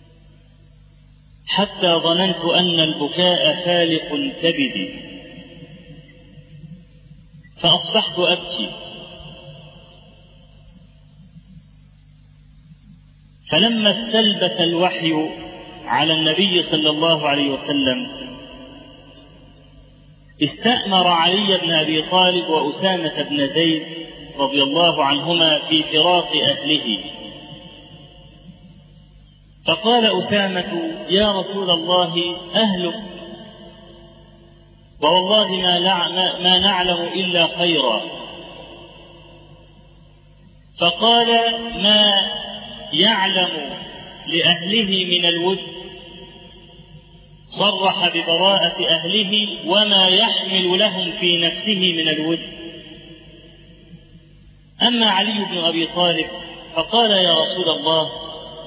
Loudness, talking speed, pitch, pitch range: -16 LUFS, 70 wpm, 170 Hz, 160-185 Hz